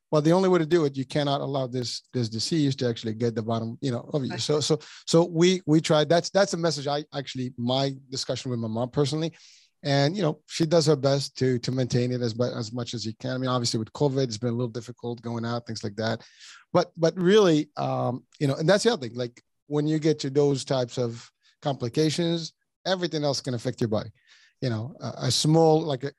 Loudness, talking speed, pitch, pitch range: -26 LUFS, 240 wpm, 135 Hz, 120-155 Hz